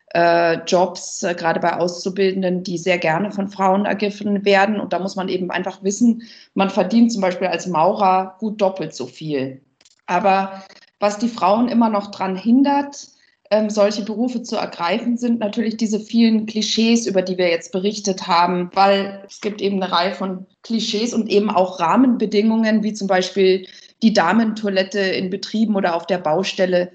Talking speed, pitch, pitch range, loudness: 165 wpm, 195 Hz, 185-215 Hz, -19 LUFS